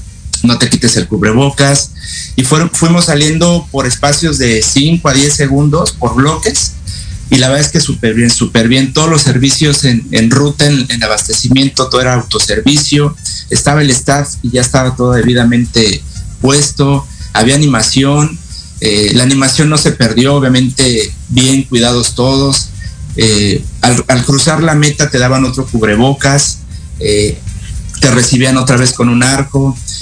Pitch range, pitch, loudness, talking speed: 110-140 Hz, 130 Hz, -9 LUFS, 155 wpm